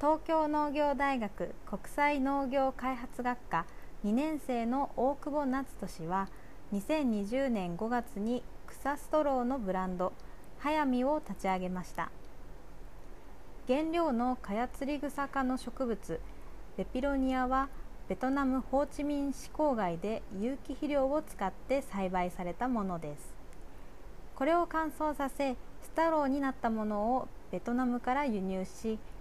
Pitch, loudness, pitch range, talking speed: 255 Hz, -34 LUFS, 205-280 Hz, 255 characters per minute